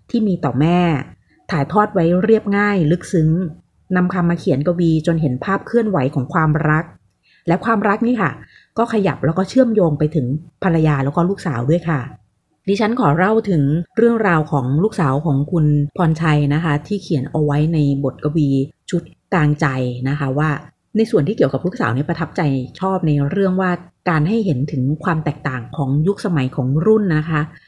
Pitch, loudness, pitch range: 160 Hz, -18 LUFS, 145-185 Hz